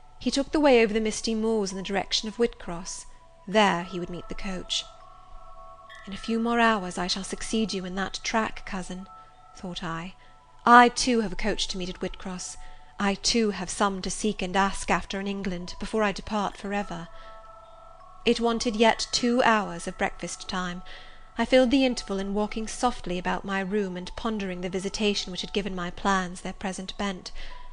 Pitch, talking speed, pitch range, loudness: 200 Hz, 190 wpm, 185-225 Hz, -26 LUFS